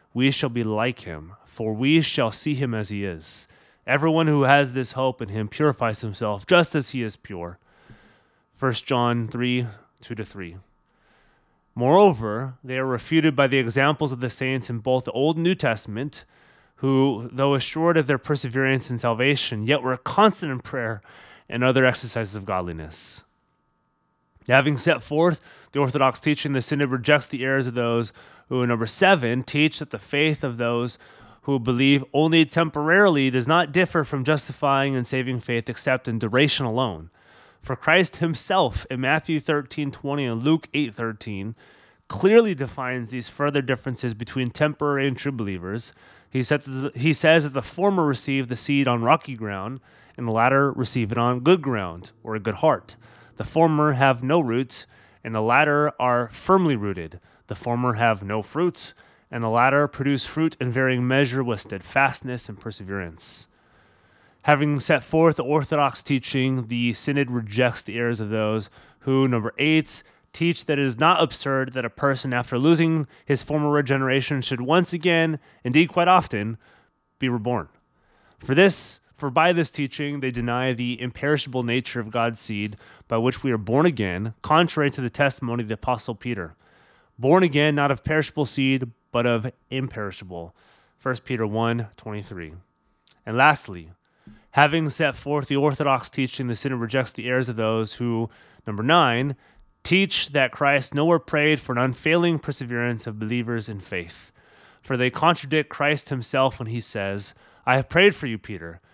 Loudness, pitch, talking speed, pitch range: -22 LUFS, 130 Hz, 170 wpm, 115-145 Hz